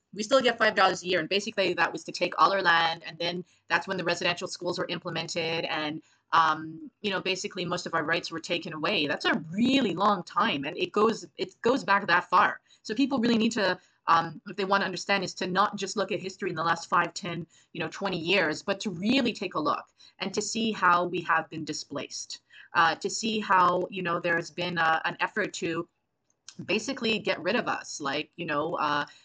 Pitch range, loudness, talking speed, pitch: 165-200 Hz, -27 LUFS, 230 wpm, 180 Hz